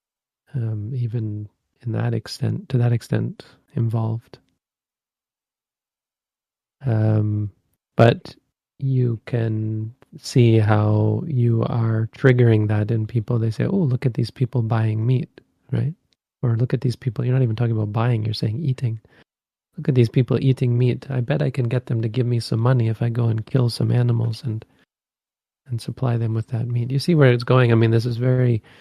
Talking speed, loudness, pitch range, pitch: 180 wpm, -21 LUFS, 115-125 Hz, 120 Hz